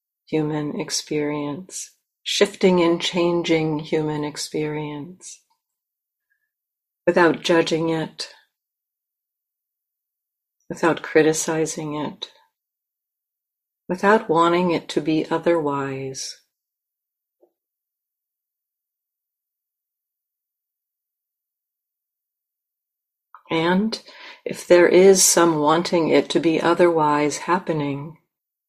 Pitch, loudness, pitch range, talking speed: 165 Hz, -20 LUFS, 155-180 Hz, 65 wpm